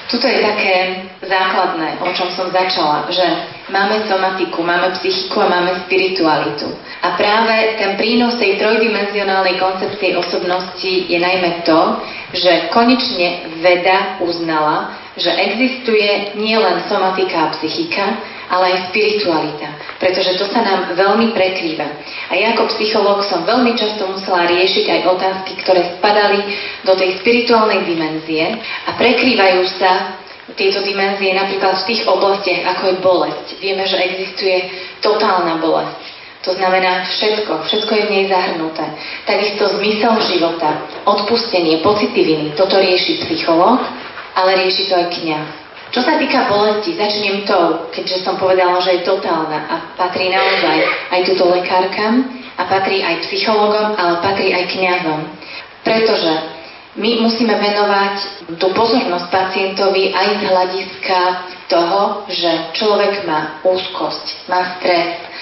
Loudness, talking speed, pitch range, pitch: -15 LUFS, 130 wpm, 180-205 Hz, 190 Hz